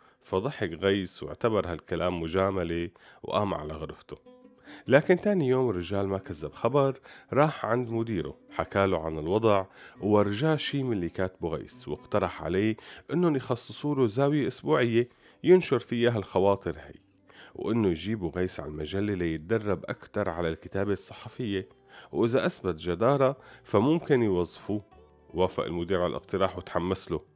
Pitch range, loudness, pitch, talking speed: 95-135 Hz, -28 LUFS, 105 Hz, 130 wpm